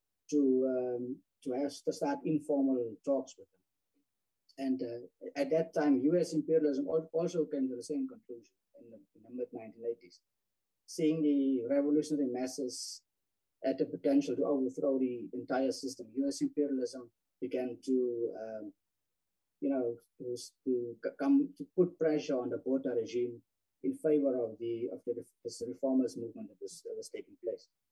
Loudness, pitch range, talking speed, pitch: -34 LUFS, 115-150 Hz, 155 wpm, 130 Hz